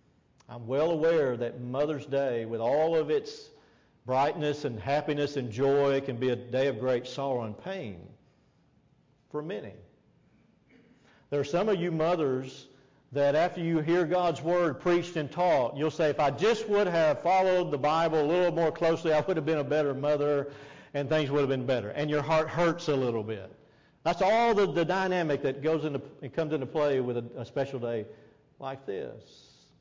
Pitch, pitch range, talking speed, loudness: 145 Hz, 135-165 Hz, 190 wpm, -28 LUFS